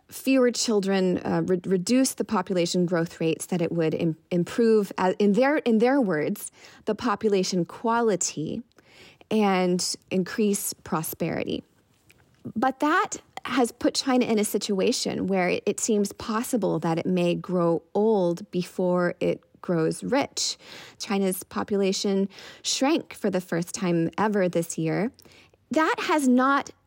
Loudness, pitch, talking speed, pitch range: -25 LUFS, 200 Hz, 135 wpm, 180-235 Hz